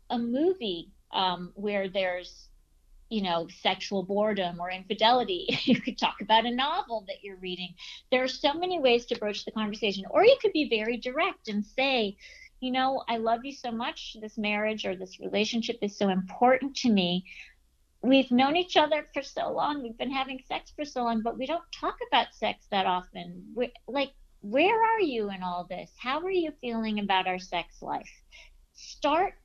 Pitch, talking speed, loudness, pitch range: 230 Hz, 190 wpm, -28 LUFS, 200-270 Hz